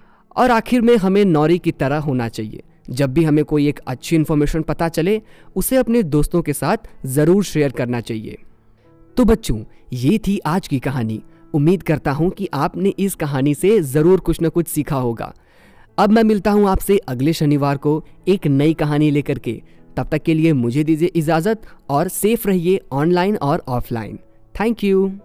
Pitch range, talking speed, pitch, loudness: 140-190 Hz, 180 wpm, 160 Hz, -18 LUFS